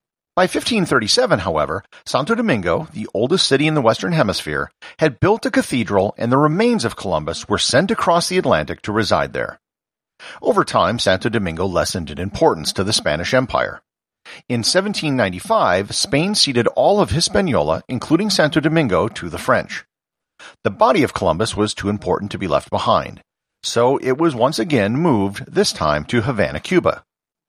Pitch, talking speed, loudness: 140 Hz, 165 wpm, -18 LUFS